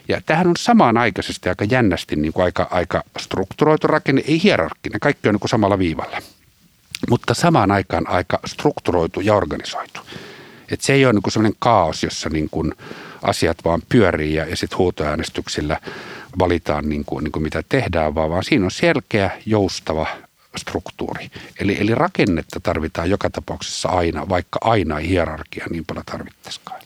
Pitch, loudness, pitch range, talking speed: 95 Hz, -19 LUFS, 80-115 Hz, 165 wpm